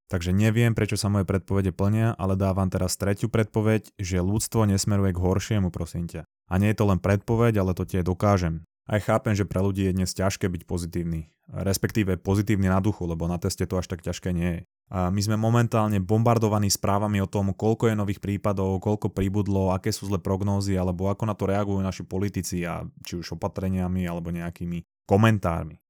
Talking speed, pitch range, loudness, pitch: 195 wpm, 90-105 Hz, -25 LUFS, 95 Hz